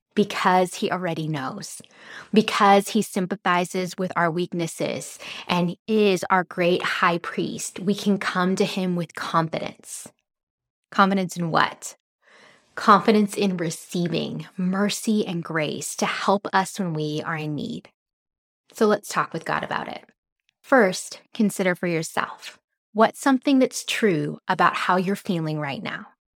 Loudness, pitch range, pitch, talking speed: -23 LUFS, 175-205 Hz, 190 Hz, 140 wpm